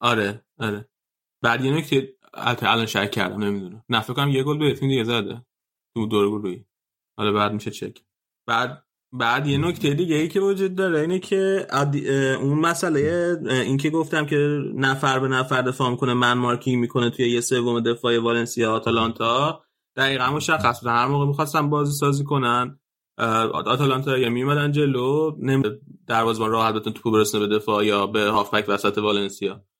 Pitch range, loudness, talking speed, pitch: 115-145 Hz, -22 LUFS, 165 wpm, 125 Hz